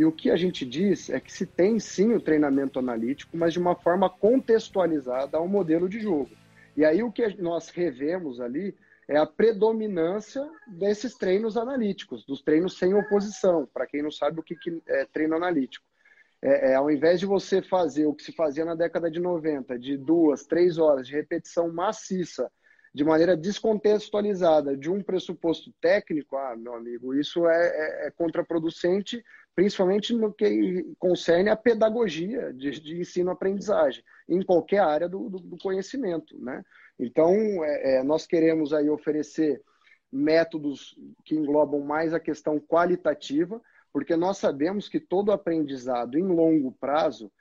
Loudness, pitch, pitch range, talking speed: -25 LUFS, 170 Hz, 155-200 Hz, 160 wpm